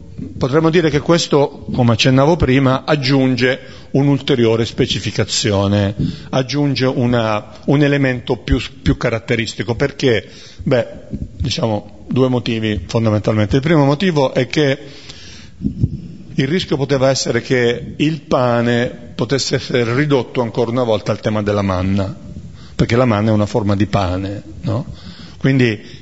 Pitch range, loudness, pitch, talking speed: 110-140 Hz, -16 LUFS, 125 Hz, 125 wpm